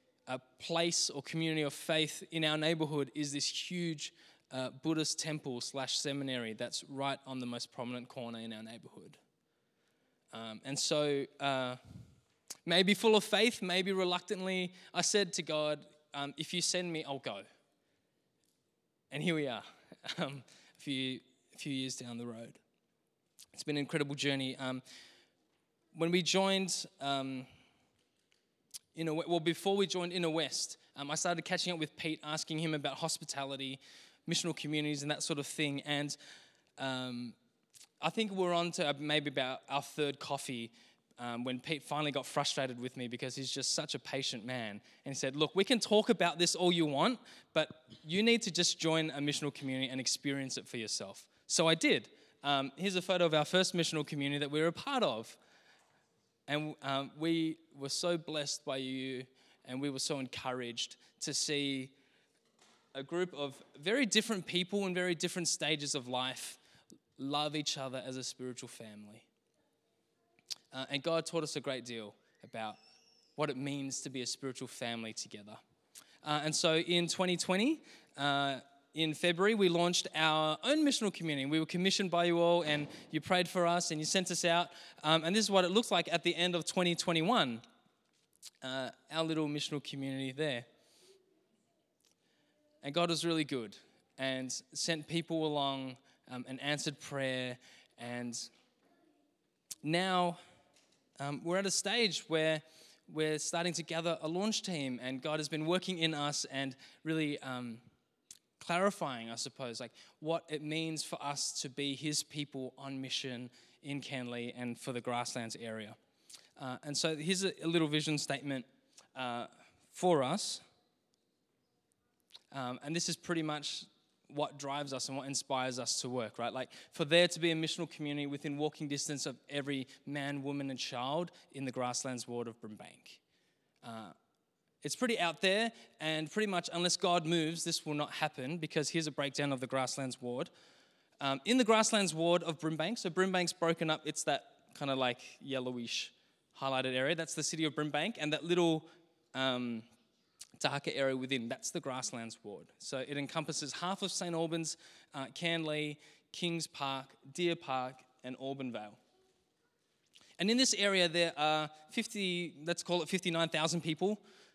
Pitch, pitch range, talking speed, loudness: 150 Hz, 135-170 Hz, 170 wpm, -35 LUFS